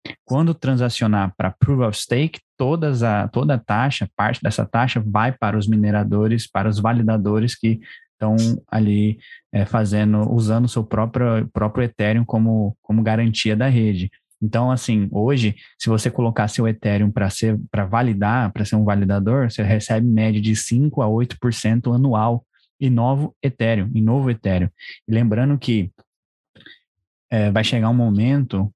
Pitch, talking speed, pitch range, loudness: 110 Hz, 150 wpm, 105-120 Hz, -19 LUFS